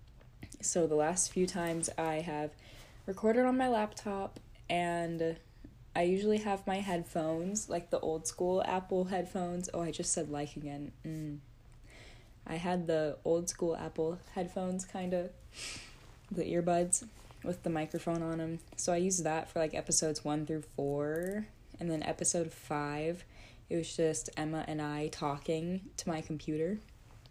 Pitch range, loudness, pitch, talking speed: 150-180 Hz, -35 LUFS, 165 Hz, 155 wpm